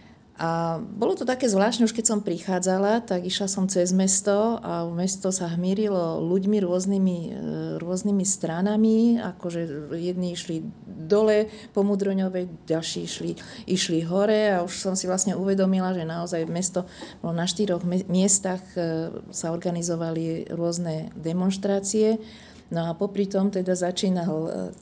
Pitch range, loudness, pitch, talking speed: 170-200 Hz, -25 LUFS, 185 Hz, 135 wpm